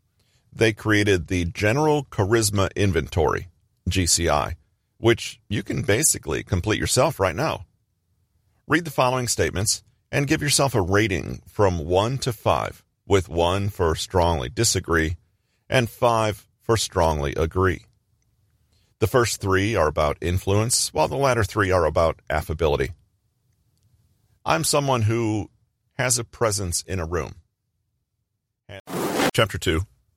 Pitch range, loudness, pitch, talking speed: 95-115 Hz, -22 LUFS, 105 Hz, 125 wpm